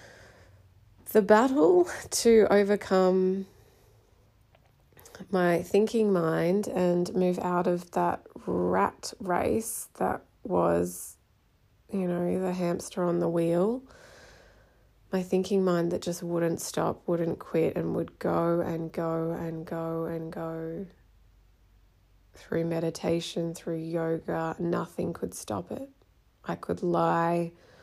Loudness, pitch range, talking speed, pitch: -28 LUFS, 160-185 Hz, 110 wpm, 170 Hz